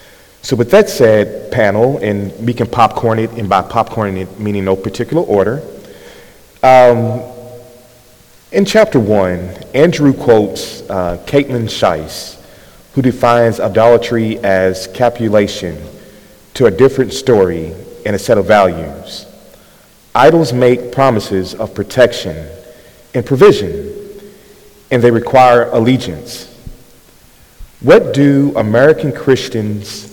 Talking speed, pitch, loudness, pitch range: 110 wpm, 120 Hz, -12 LUFS, 105-130 Hz